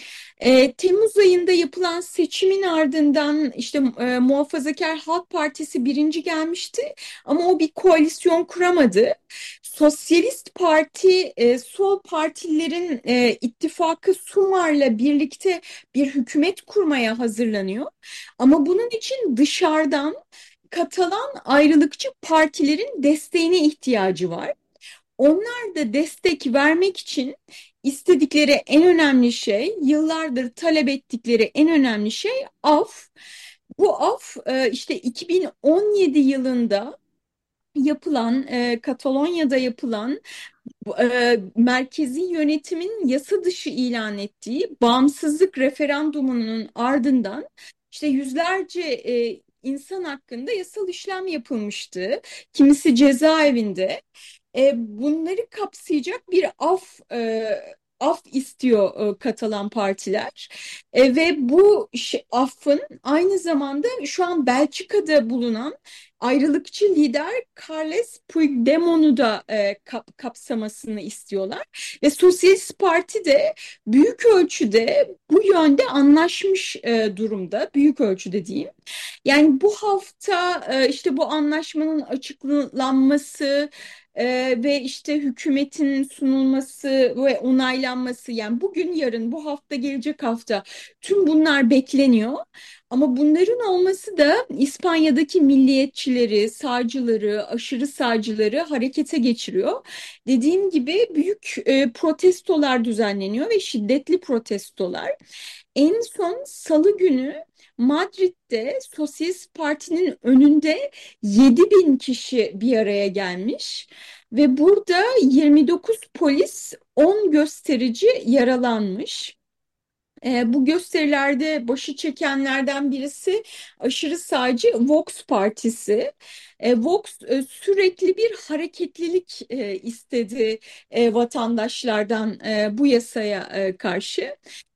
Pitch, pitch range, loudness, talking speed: 290 Hz, 250-345 Hz, -20 LUFS, 95 wpm